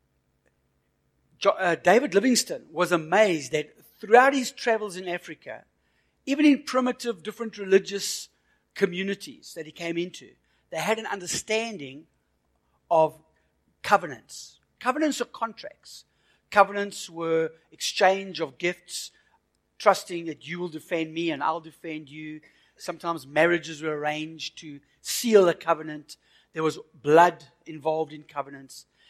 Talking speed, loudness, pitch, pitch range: 120 wpm, -25 LUFS, 170 Hz, 155-205 Hz